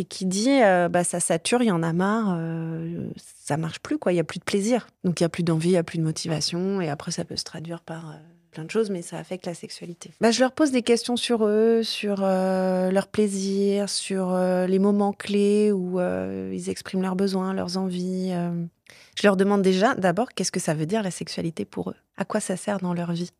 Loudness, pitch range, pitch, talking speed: -24 LUFS, 170-205 Hz, 185 Hz, 250 wpm